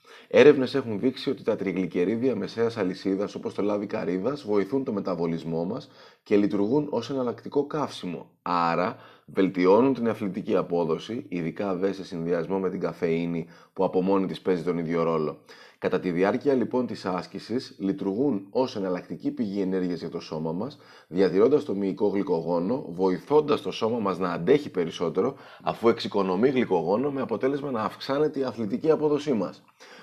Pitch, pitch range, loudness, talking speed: 100 Hz, 90-130 Hz, -26 LUFS, 155 wpm